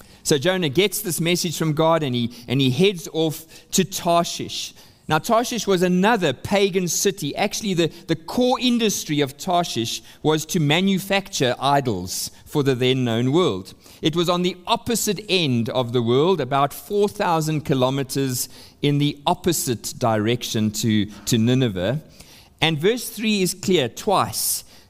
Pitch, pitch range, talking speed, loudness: 155 Hz, 125-185 Hz, 150 wpm, -21 LUFS